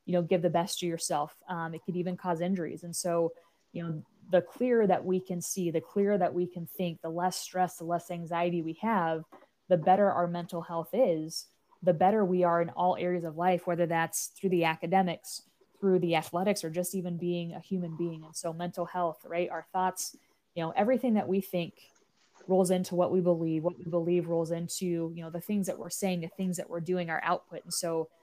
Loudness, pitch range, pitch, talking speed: -31 LUFS, 170-185 Hz, 175 Hz, 225 wpm